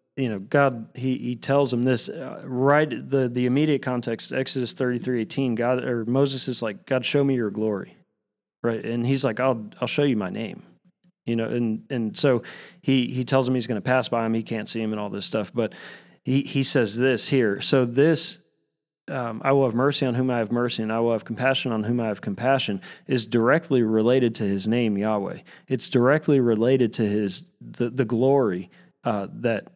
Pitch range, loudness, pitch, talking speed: 115-135 Hz, -24 LUFS, 125 Hz, 215 wpm